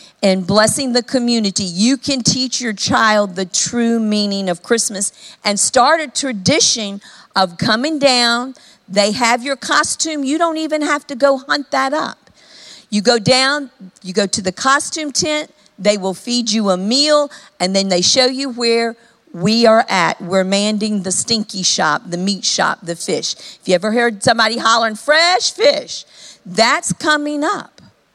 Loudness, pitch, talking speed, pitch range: -15 LUFS, 230 Hz, 170 wpm, 200-270 Hz